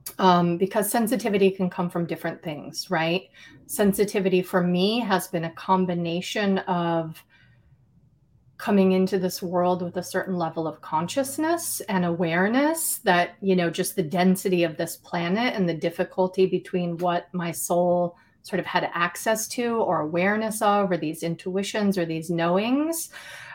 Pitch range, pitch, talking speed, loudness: 170-195 Hz, 180 Hz, 150 wpm, -24 LUFS